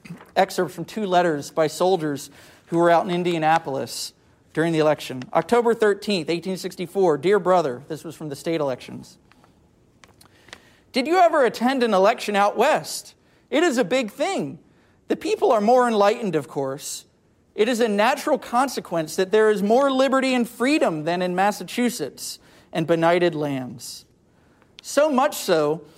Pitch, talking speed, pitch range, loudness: 185 Hz, 150 wpm, 160-235 Hz, -21 LUFS